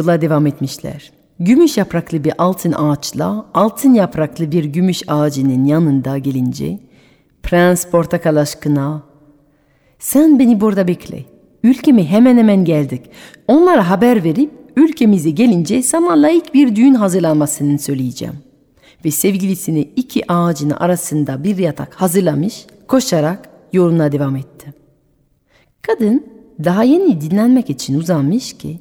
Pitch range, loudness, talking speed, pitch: 150-225 Hz, -14 LUFS, 115 wpm, 175 Hz